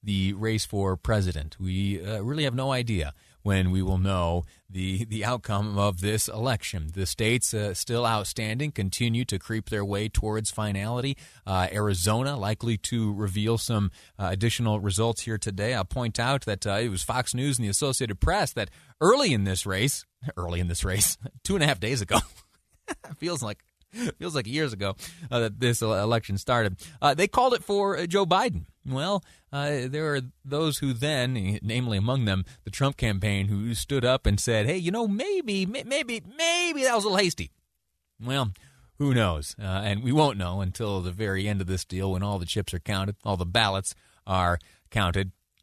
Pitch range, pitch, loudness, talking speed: 95-135 Hz, 110 Hz, -27 LUFS, 190 wpm